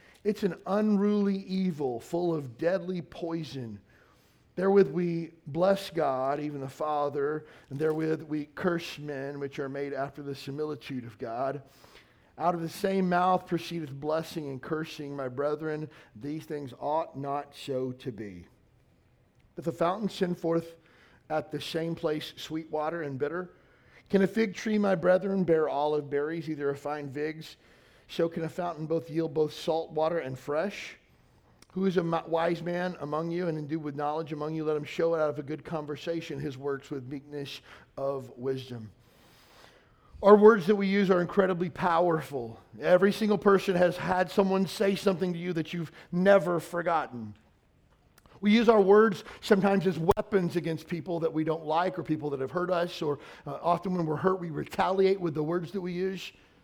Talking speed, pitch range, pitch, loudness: 175 wpm, 145-180 Hz, 160 Hz, -29 LUFS